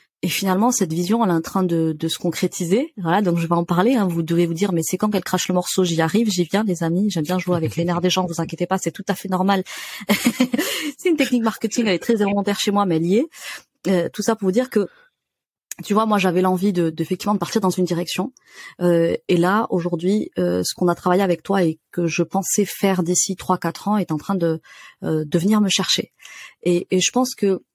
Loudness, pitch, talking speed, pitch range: -20 LUFS, 185 Hz, 255 wpm, 175-205 Hz